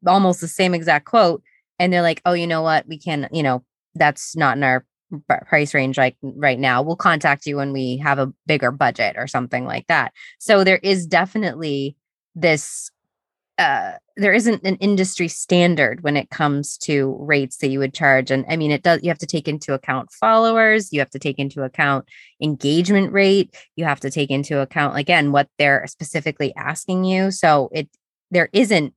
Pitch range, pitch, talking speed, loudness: 140-180 Hz, 150 Hz, 195 wpm, -18 LUFS